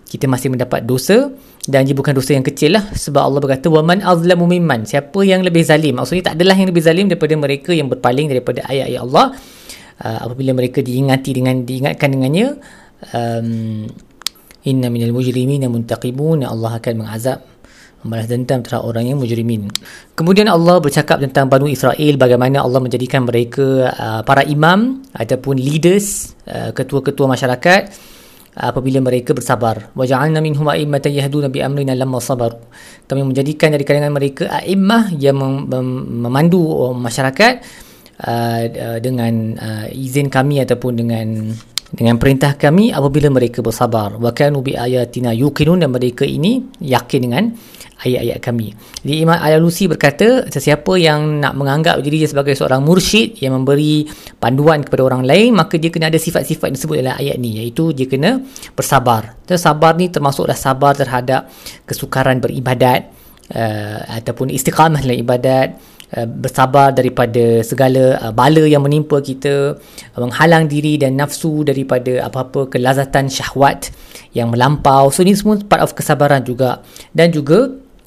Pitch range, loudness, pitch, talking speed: 125-155 Hz, -14 LUFS, 135 Hz, 150 wpm